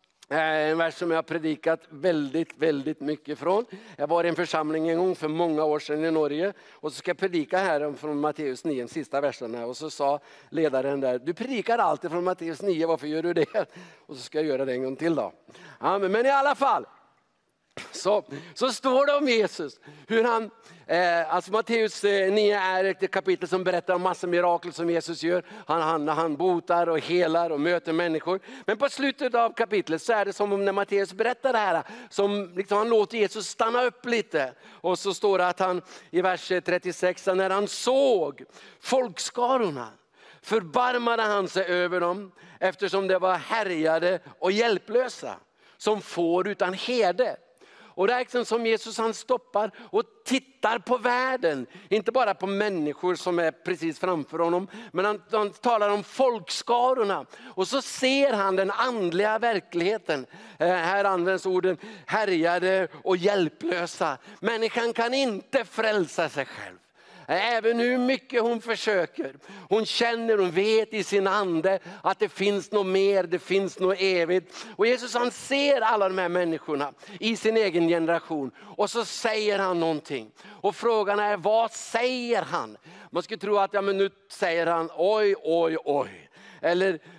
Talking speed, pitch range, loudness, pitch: 175 wpm, 170-220 Hz, -26 LUFS, 190 Hz